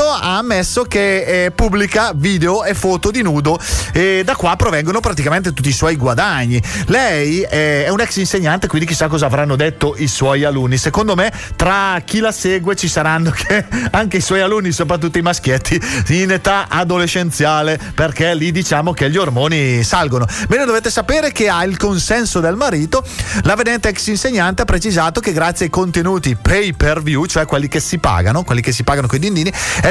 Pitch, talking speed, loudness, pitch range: 170 Hz, 185 wpm, -14 LUFS, 150-195 Hz